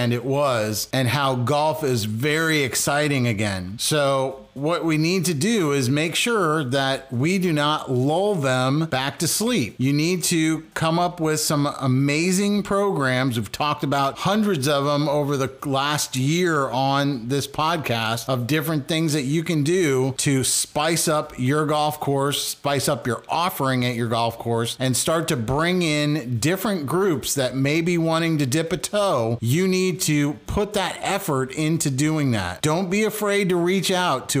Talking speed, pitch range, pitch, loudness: 175 wpm, 130-165 Hz, 150 Hz, -21 LUFS